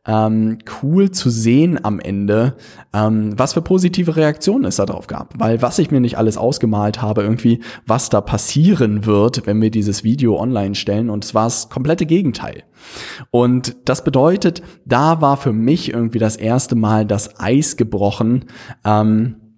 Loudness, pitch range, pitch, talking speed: -16 LUFS, 110-135 Hz, 115 Hz, 170 wpm